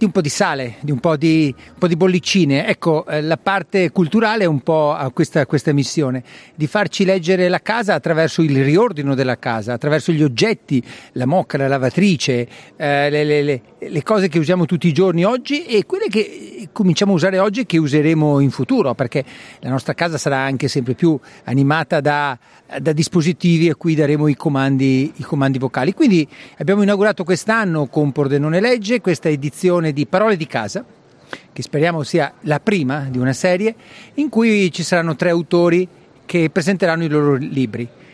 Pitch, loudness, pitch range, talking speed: 160 Hz, -17 LUFS, 145-185 Hz, 185 wpm